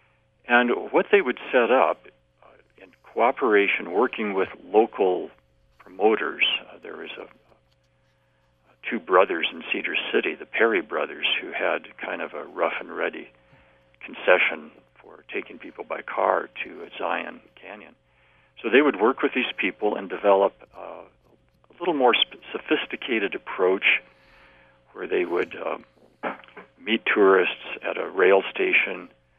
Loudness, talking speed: -23 LUFS, 145 wpm